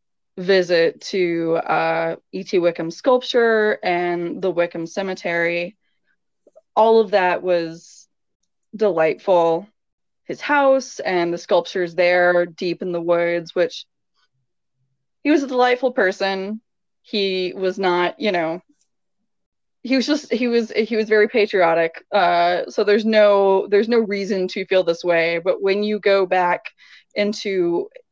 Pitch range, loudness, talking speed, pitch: 175-215 Hz, -19 LUFS, 130 wpm, 185 Hz